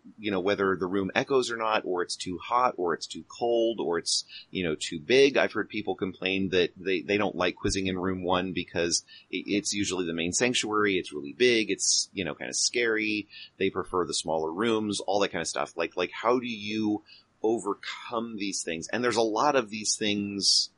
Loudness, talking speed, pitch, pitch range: -27 LUFS, 215 wpm, 100 Hz, 95-110 Hz